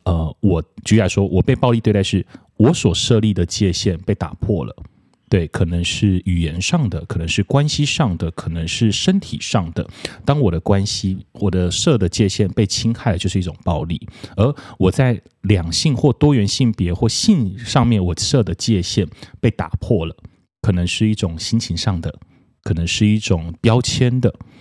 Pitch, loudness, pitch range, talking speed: 105 Hz, -18 LUFS, 90-120 Hz, 260 characters per minute